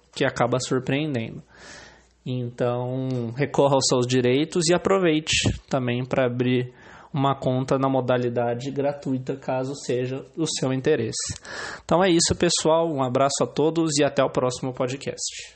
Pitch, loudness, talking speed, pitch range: 130 Hz, -23 LUFS, 140 wpm, 125-145 Hz